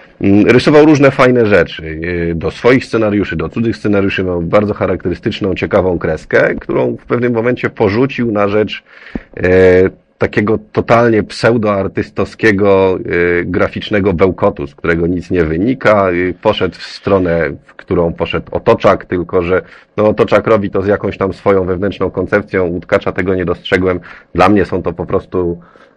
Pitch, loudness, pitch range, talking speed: 95 Hz, -13 LUFS, 90-105 Hz, 140 wpm